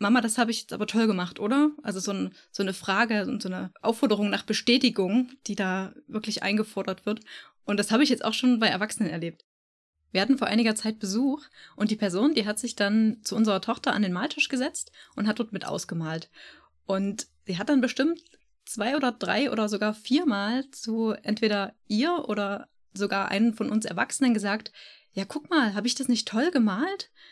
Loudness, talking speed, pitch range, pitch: -27 LUFS, 200 wpm, 200-250 Hz, 220 Hz